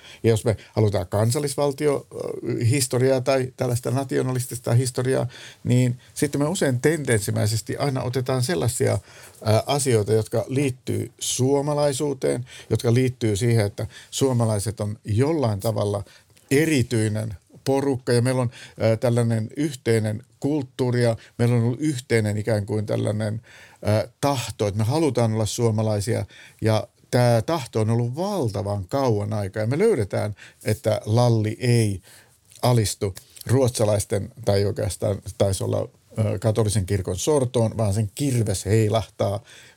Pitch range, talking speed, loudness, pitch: 110-130 Hz, 120 wpm, -23 LUFS, 115 Hz